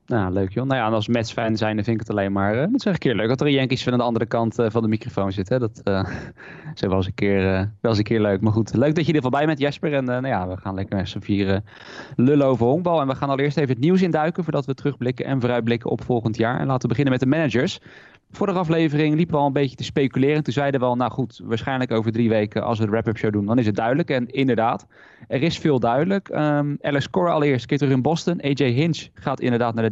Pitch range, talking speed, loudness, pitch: 110-145 Hz, 295 wpm, -21 LUFS, 125 Hz